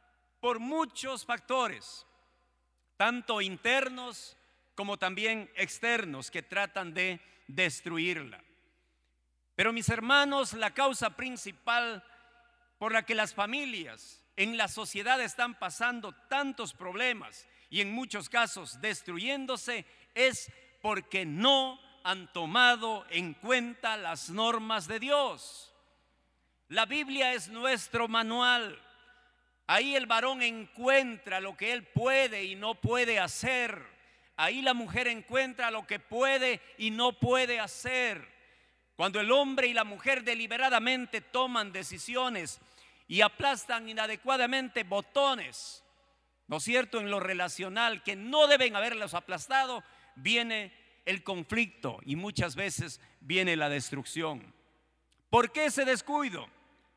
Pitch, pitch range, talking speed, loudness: 230 Hz, 195-255 Hz, 115 wpm, -30 LUFS